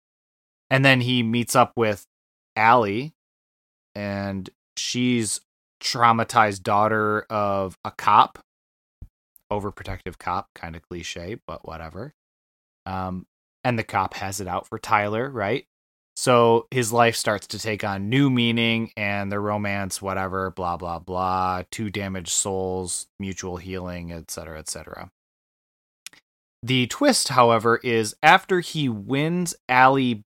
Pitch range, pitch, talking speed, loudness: 90-115 Hz, 100 Hz, 125 wpm, -22 LUFS